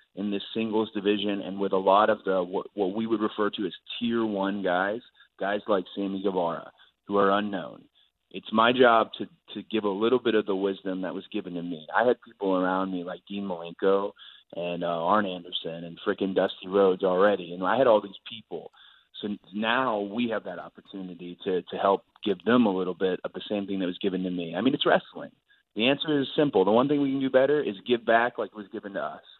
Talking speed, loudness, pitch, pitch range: 235 wpm, -26 LUFS, 100 Hz, 95-110 Hz